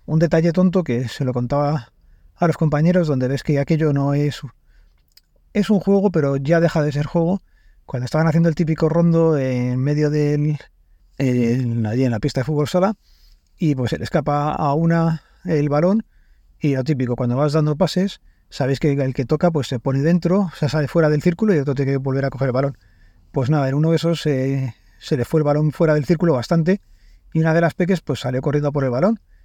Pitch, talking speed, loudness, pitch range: 150 Hz, 215 wpm, -19 LUFS, 130-165 Hz